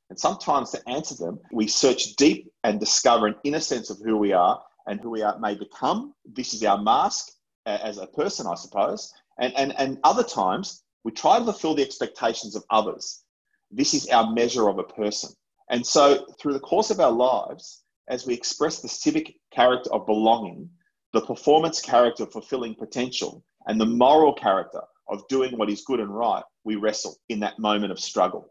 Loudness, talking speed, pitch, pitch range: -23 LUFS, 195 wpm, 120 Hz, 110-160 Hz